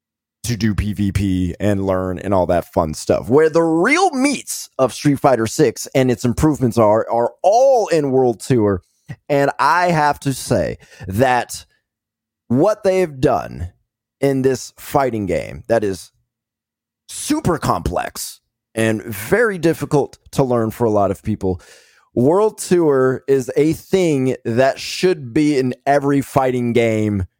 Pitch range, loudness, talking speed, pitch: 105-145 Hz, -17 LUFS, 145 wpm, 125 Hz